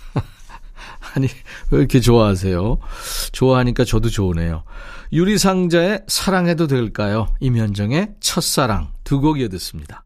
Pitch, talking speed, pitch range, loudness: 130 Hz, 285 characters per minute, 105-170 Hz, -18 LUFS